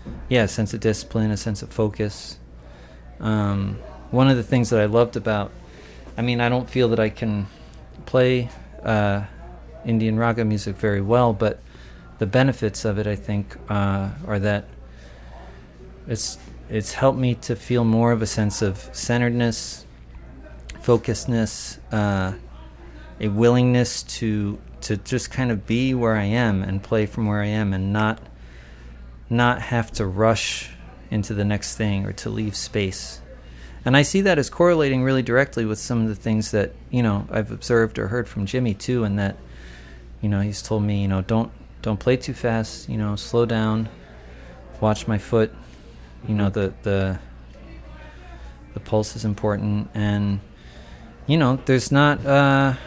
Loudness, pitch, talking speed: -22 LUFS, 105 Hz, 165 wpm